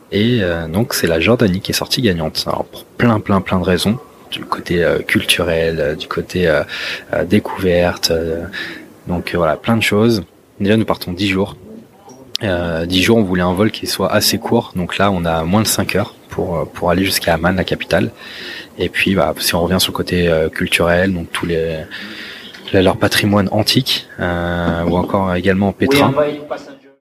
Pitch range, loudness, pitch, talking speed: 85-105 Hz, -16 LUFS, 95 Hz, 190 wpm